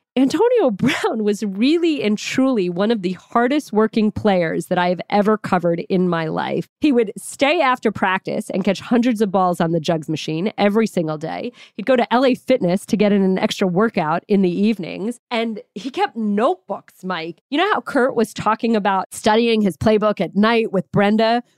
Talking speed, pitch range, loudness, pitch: 195 wpm, 185-235 Hz, -19 LUFS, 210 Hz